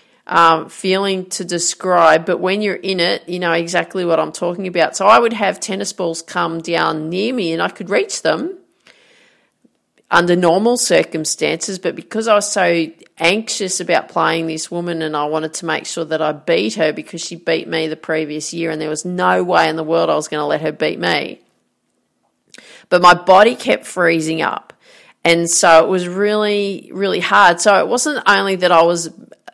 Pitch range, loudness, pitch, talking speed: 160-195 Hz, -16 LUFS, 170 Hz, 195 wpm